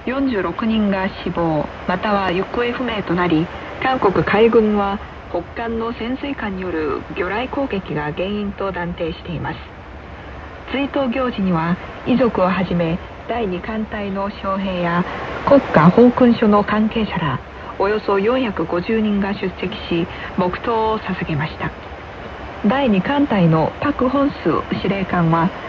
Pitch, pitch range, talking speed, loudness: 200 Hz, 175-230 Hz, 235 characters per minute, -19 LUFS